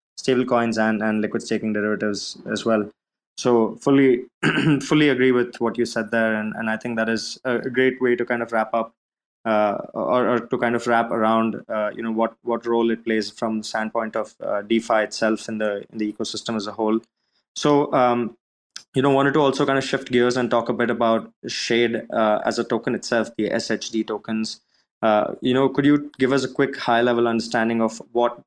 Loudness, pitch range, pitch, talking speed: -22 LUFS, 110-125 Hz, 115 Hz, 215 wpm